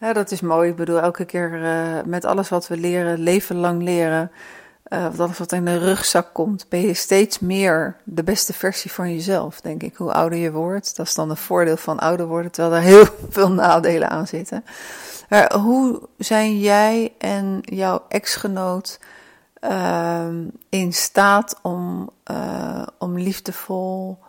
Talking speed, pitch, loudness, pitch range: 170 wpm, 180 Hz, -19 LUFS, 170-200 Hz